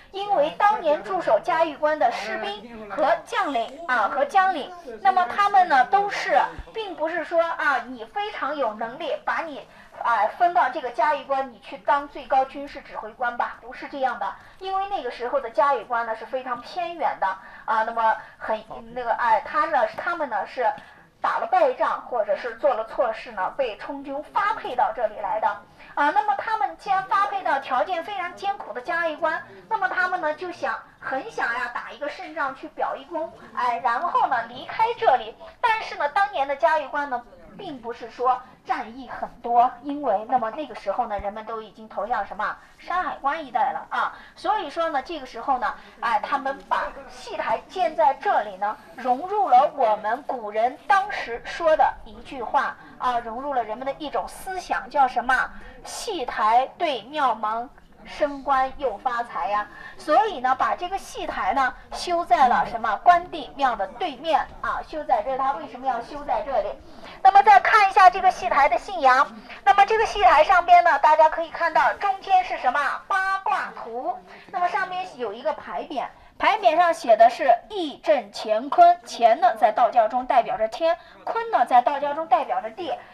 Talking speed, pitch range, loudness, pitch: 270 characters per minute, 255-365 Hz, -23 LUFS, 305 Hz